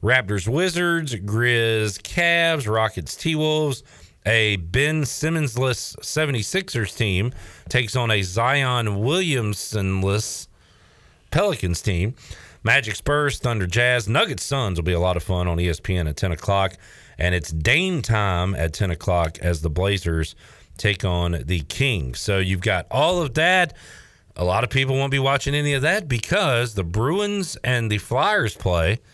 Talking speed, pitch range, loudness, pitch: 150 wpm, 90-135 Hz, -21 LUFS, 110 Hz